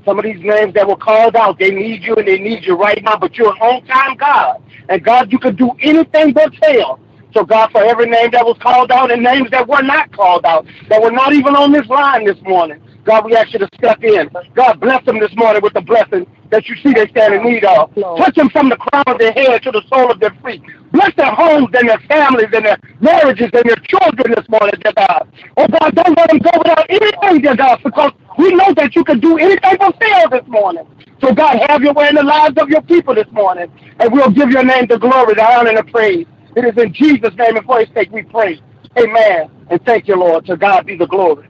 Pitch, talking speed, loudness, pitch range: 245 Hz, 255 wpm, -10 LUFS, 215-295 Hz